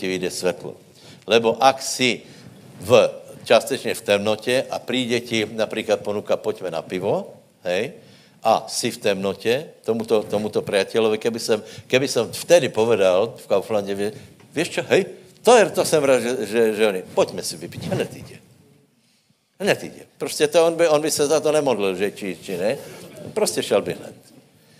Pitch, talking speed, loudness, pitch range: 120 Hz, 170 wpm, -21 LUFS, 105-150 Hz